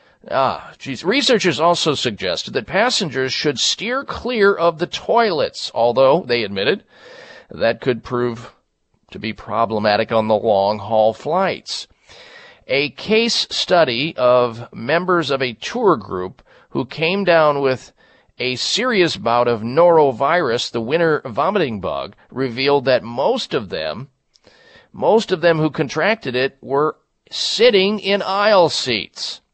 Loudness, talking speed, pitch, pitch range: -18 LUFS, 130 wpm, 145 Hz, 120-195 Hz